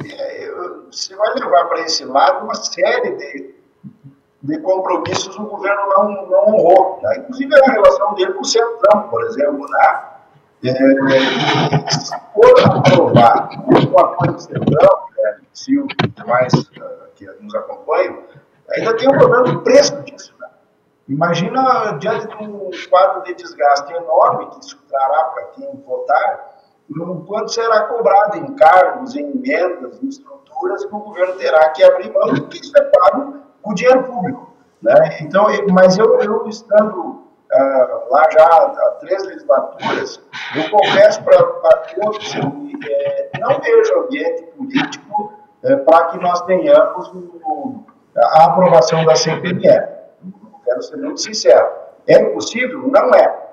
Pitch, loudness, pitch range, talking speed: 220 Hz, -14 LUFS, 180-290 Hz, 150 wpm